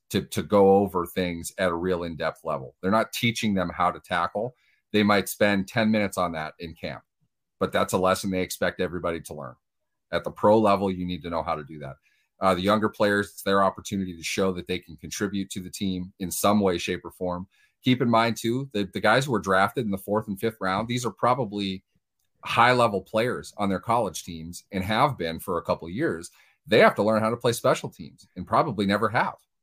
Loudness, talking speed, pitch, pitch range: -25 LUFS, 235 wpm, 100 Hz, 90-110 Hz